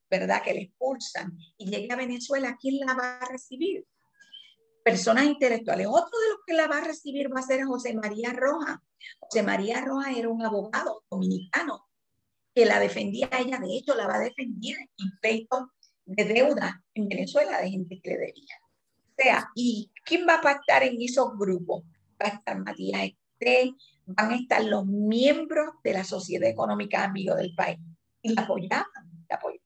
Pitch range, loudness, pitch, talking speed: 200-275 Hz, -27 LUFS, 245 Hz, 180 wpm